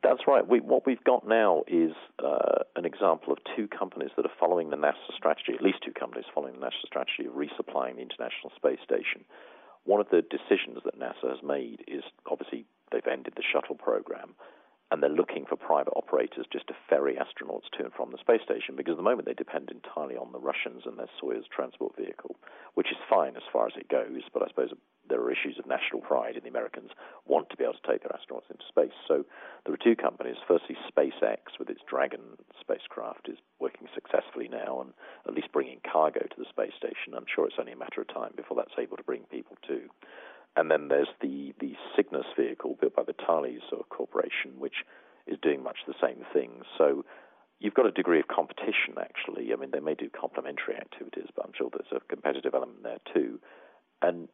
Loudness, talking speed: -30 LUFS, 215 wpm